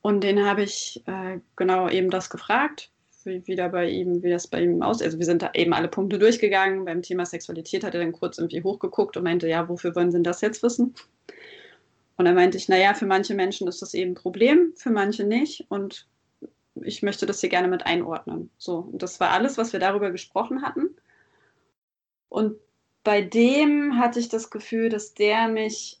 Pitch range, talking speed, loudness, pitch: 180-225 Hz, 210 wpm, -24 LUFS, 195 Hz